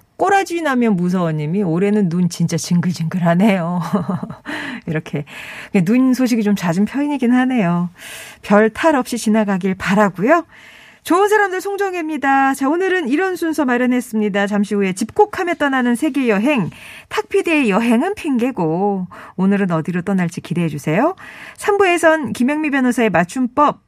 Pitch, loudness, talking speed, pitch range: 230 Hz, -17 LUFS, 325 characters per minute, 195-295 Hz